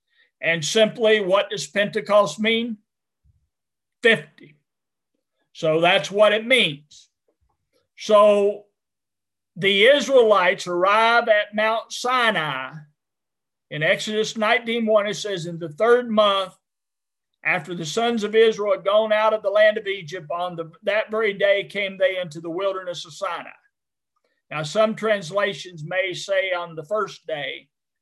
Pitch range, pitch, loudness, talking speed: 180-220 Hz, 205 Hz, -20 LUFS, 135 wpm